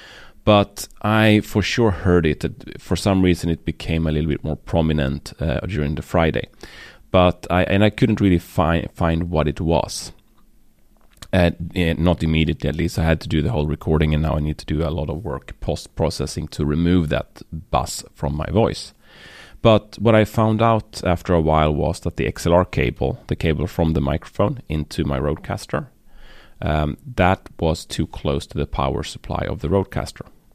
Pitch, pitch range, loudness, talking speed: 85 Hz, 75-95 Hz, -20 LUFS, 190 wpm